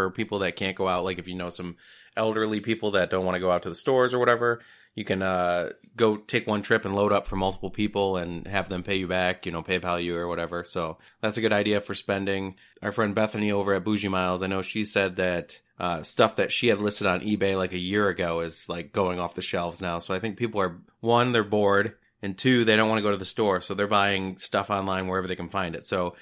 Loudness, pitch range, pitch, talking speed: -26 LUFS, 90-105 Hz, 95 Hz, 265 wpm